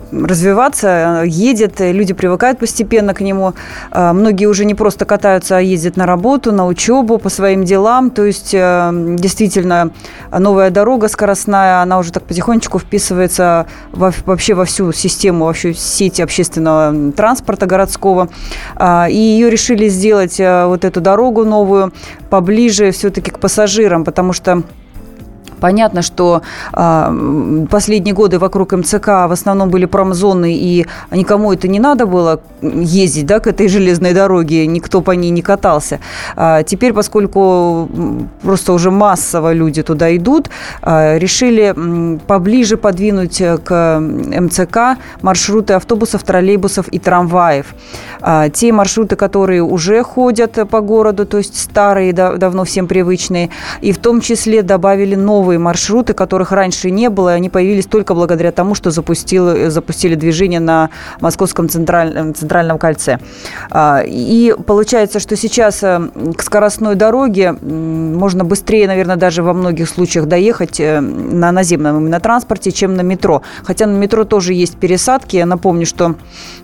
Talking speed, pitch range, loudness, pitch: 140 wpm, 175-210 Hz, -11 LUFS, 190 Hz